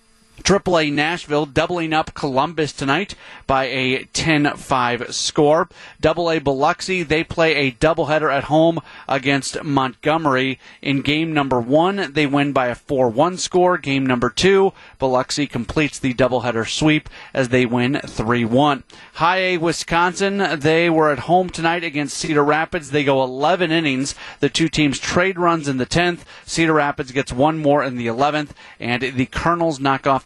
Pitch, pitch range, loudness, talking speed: 150 Hz, 135-165 Hz, -18 LUFS, 165 wpm